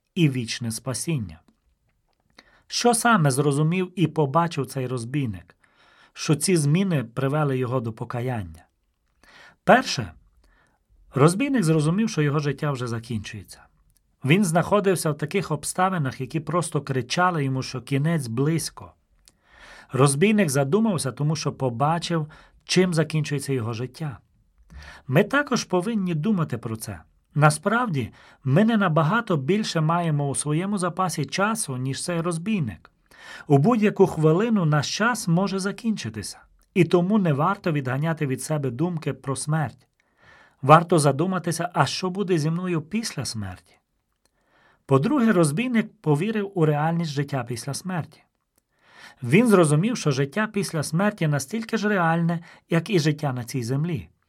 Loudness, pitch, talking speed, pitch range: -23 LUFS, 155 Hz, 125 wpm, 130-180 Hz